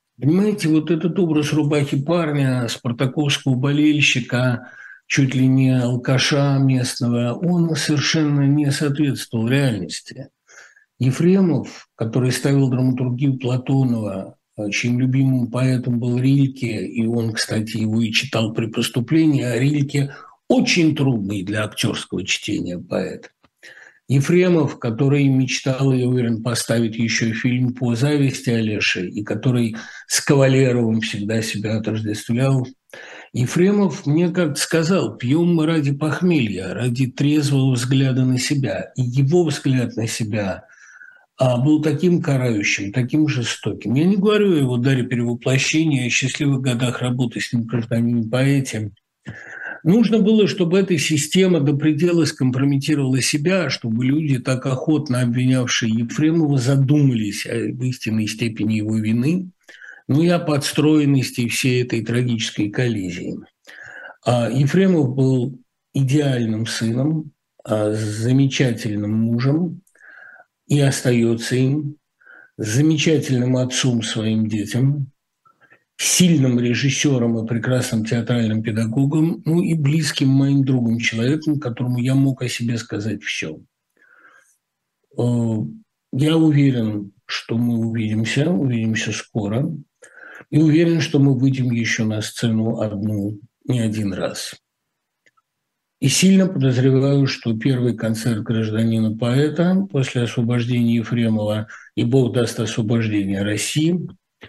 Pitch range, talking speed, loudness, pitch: 115-145 Hz, 115 wpm, -19 LUFS, 130 Hz